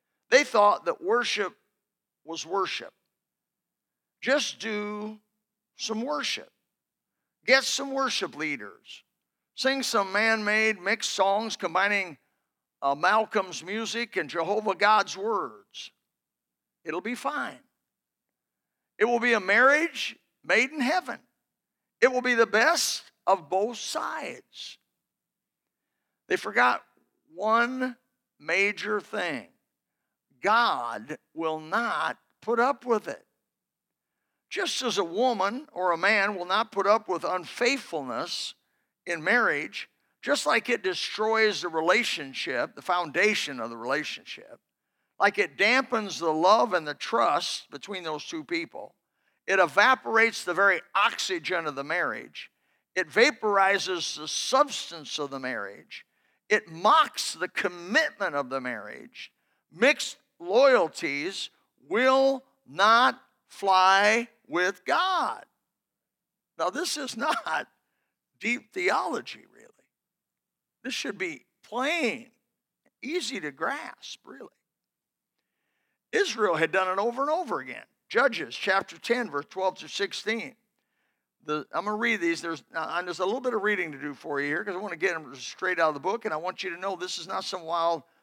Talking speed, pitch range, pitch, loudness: 135 wpm, 180-250 Hz, 210 Hz, -26 LUFS